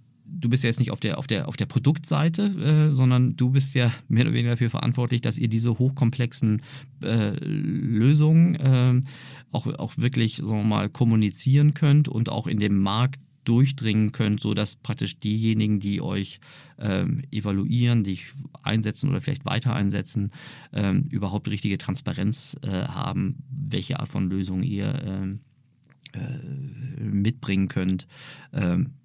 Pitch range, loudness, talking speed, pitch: 110-140 Hz, -24 LUFS, 155 wpm, 125 Hz